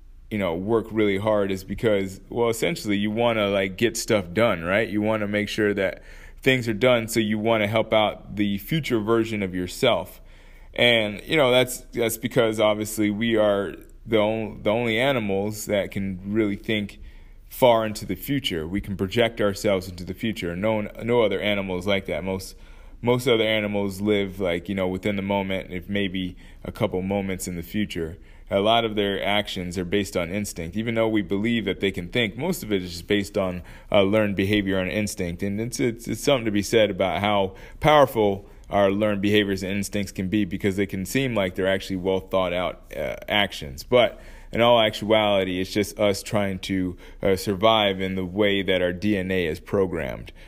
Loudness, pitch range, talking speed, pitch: -23 LUFS, 95-110 Hz, 195 wpm, 100 Hz